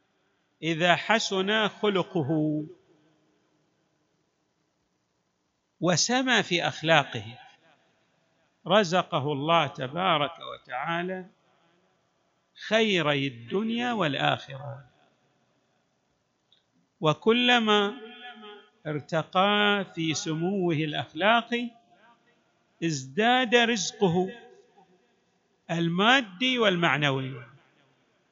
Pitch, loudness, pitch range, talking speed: 180 Hz, -25 LUFS, 155-215 Hz, 45 wpm